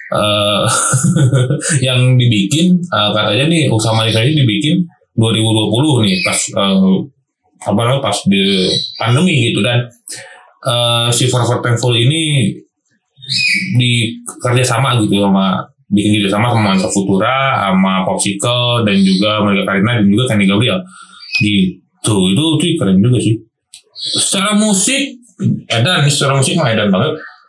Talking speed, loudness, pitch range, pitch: 130 wpm, -13 LUFS, 105-135 Hz, 120 Hz